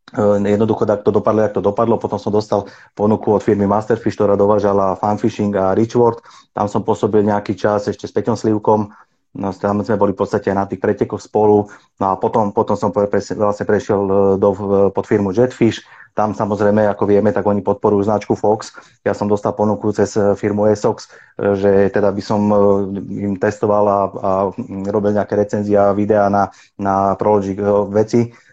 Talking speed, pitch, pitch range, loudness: 180 wpm, 105 Hz, 100-105 Hz, -16 LUFS